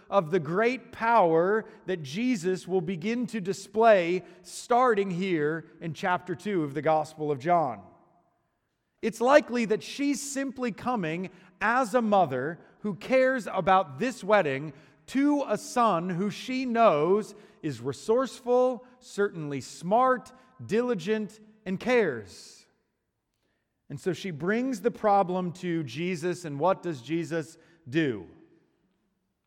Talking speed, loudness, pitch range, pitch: 120 wpm, -27 LUFS, 170-235 Hz, 195 Hz